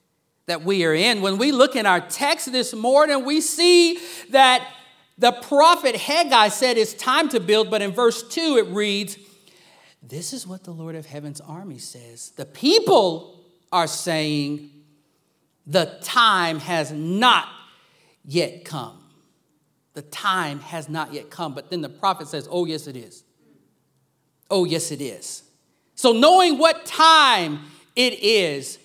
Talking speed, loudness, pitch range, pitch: 150 wpm, -19 LUFS, 160-255 Hz, 195 Hz